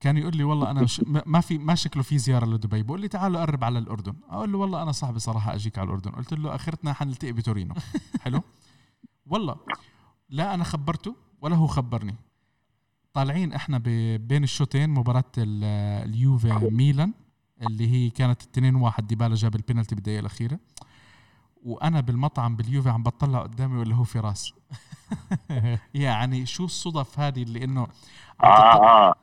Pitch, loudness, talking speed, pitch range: 125 Hz, -24 LUFS, 155 wpm, 115-150 Hz